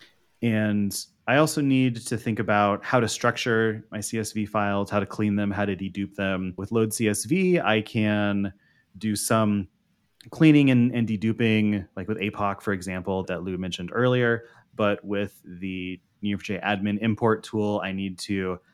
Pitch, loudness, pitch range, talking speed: 105 Hz, -25 LUFS, 100-115 Hz, 165 wpm